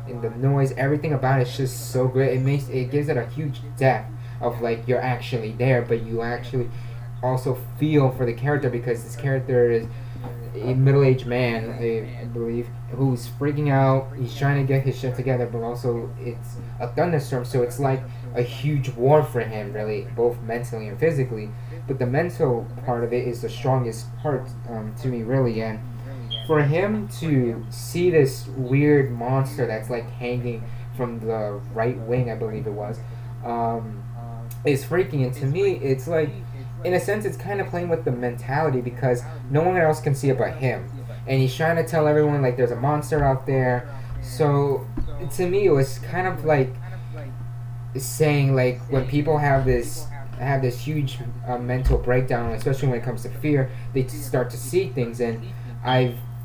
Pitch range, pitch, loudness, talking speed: 120-135 Hz, 125 Hz, -23 LUFS, 185 wpm